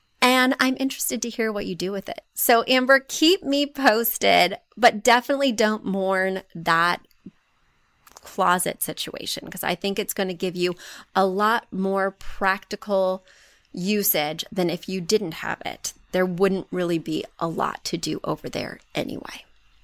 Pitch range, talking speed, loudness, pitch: 185-240 Hz, 155 wpm, -23 LUFS, 195 Hz